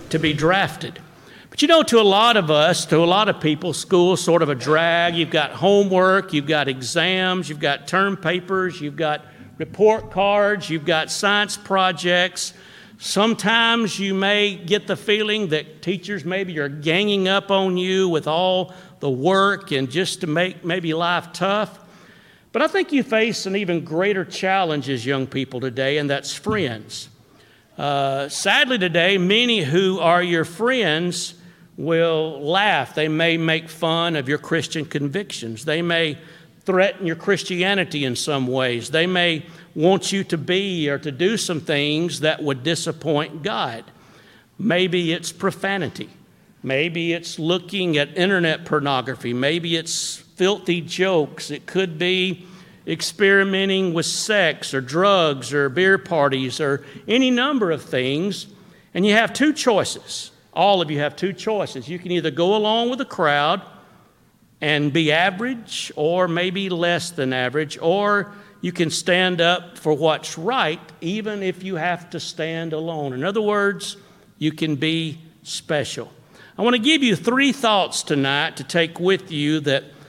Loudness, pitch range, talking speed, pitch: -20 LUFS, 155-195 Hz, 160 wpm, 175 Hz